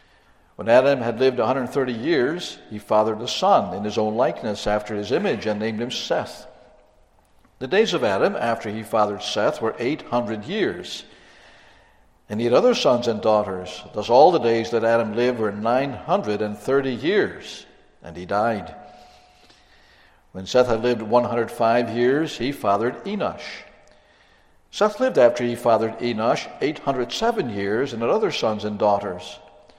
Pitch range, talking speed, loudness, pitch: 105-125 Hz, 150 wpm, -22 LUFS, 115 Hz